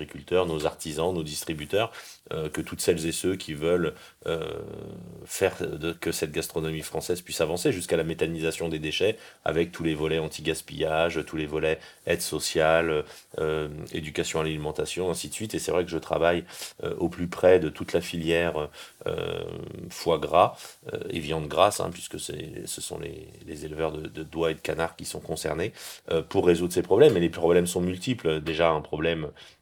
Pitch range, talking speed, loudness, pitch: 80-85 Hz, 195 wpm, -27 LUFS, 80 Hz